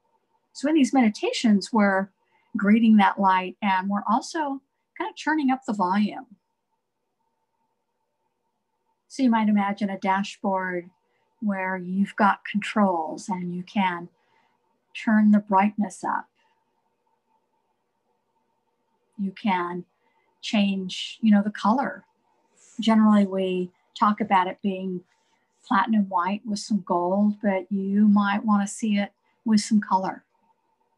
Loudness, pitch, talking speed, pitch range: -24 LUFS, 210 Hz, 120 wpm, 190-260 Hz